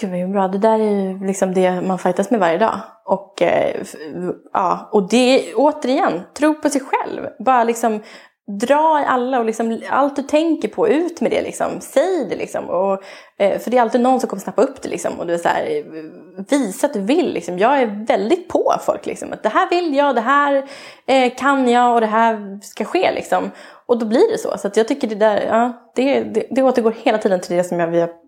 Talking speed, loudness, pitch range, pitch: 225 wpm, -18 LUFS, 205-280 Hz, 240 Hz